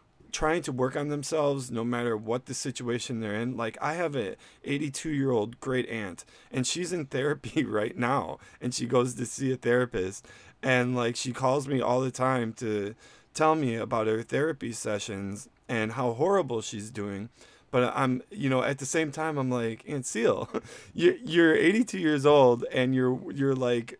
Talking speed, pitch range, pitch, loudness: 185 wpm, 115-140 Hz, 125 Hz, -28 LUFS